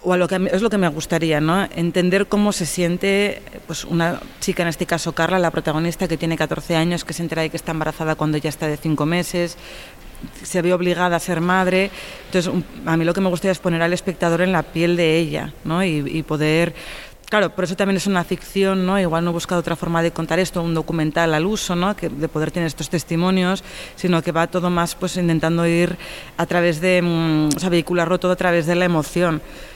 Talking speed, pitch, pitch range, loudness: 235 wpm, 175 Hz, 165-185 Hz, -20 LUFS